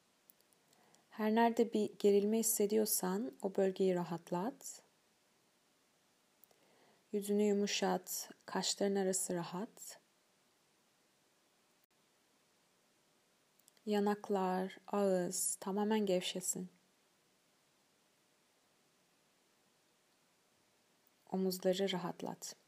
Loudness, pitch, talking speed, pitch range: -36 LUFS, 195 Hz, 50 wpm, 185-210 Hz